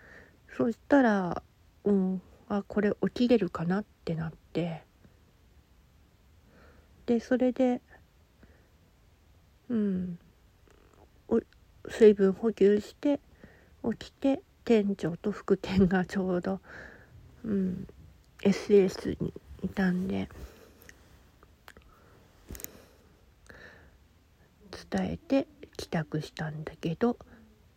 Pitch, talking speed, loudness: 170 Hz, 145 characters per minute, -29 LUFS